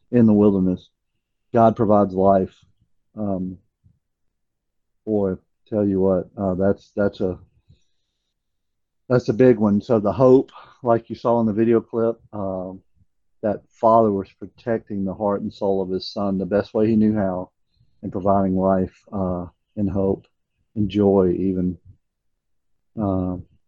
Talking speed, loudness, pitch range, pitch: 145 wpm, -21 LUFS, 95-110 Hz, 100 Hz